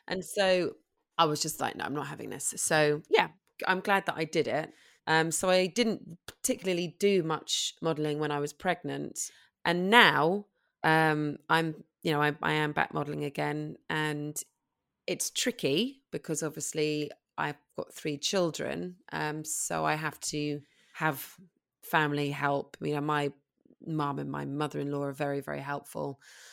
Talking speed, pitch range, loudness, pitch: 165 wpm, 145-180 Hz, -30 LUFS, 155 Hz